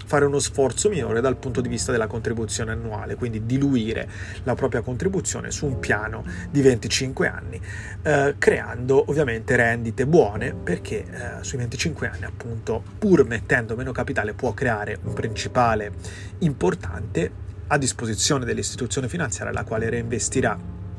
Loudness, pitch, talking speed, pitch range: -23 LUFS, 115 Hz, 140 wpm, 105-130 Hz